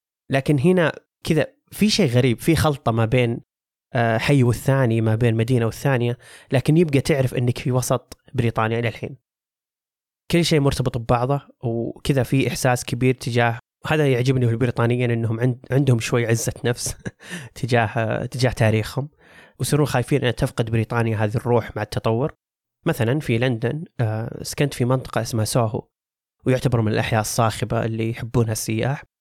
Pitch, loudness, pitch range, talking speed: 125 Hz, -21 LUFS, 115-135 Hz, 150 wpm